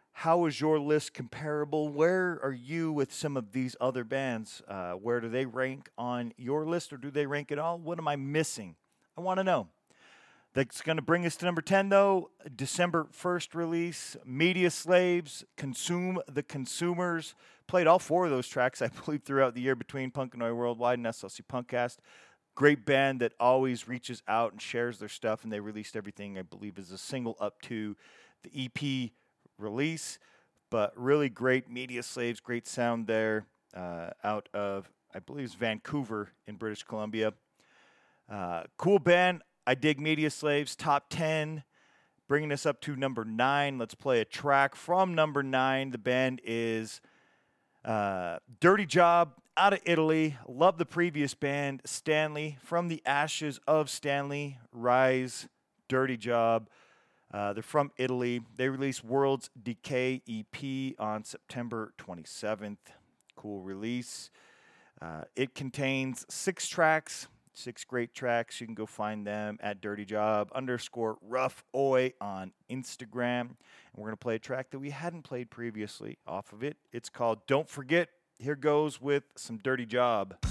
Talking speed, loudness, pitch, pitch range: 160 wpm, -31 LUFS, 130 Hz, 115-150 Hz